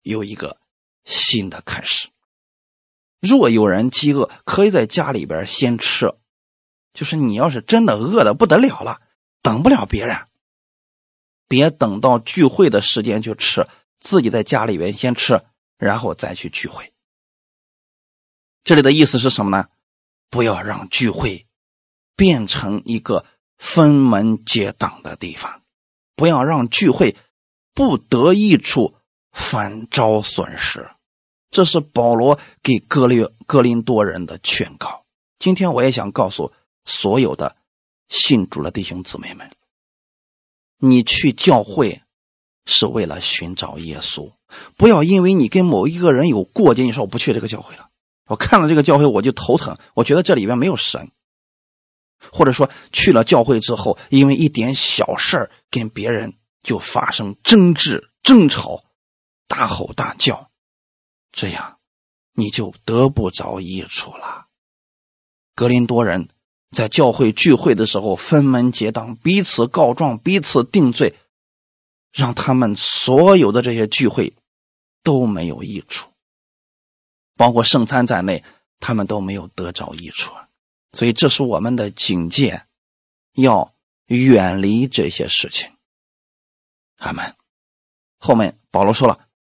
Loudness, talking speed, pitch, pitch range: -16 LUFS, 205 characters per minute, 115 Hz, 90-130 Hz